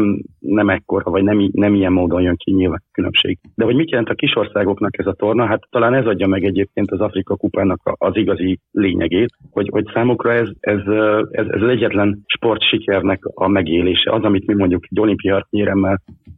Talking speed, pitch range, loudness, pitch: 195 wpm, 95-105 Hz, -17 LUFS, 100 Hz